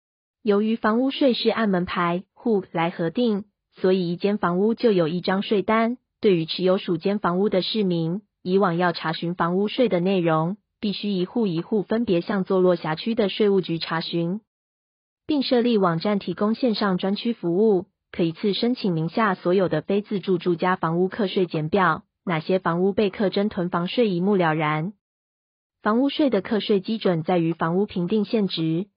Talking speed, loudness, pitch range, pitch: 270 characters per minute, -23 LUFS, 175-215 Hz, 195 Hz